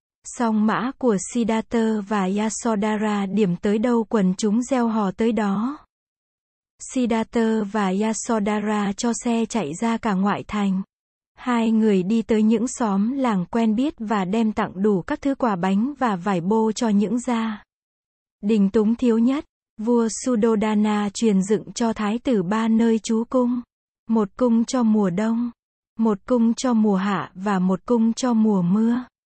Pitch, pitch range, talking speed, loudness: 225 Hz, 210-235 Hz, 160 wpm, -22 LUFS